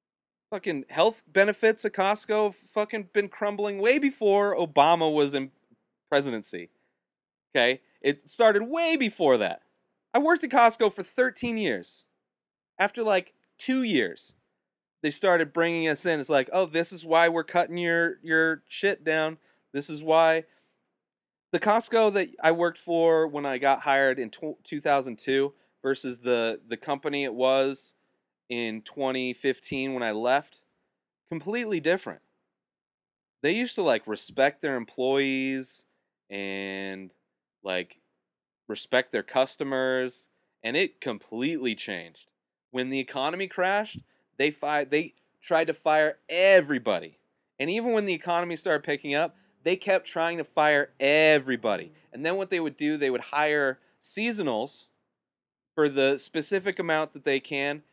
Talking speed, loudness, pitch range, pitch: 140 wpm, -26 LUFS, 135-195 Hz, 155 Hz